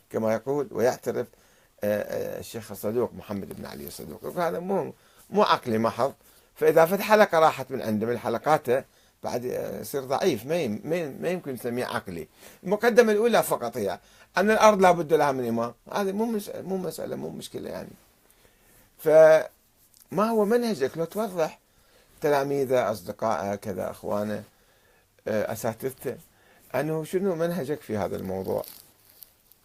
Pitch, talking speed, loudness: 150 Hz, 135 wpm, -25 LUFS